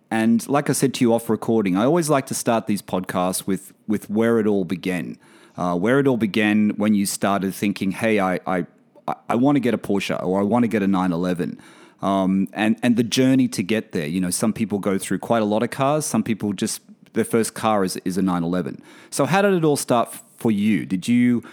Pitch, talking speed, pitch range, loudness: 110 Hz, 235 wpm, 95-120 Hz, -21 LUFS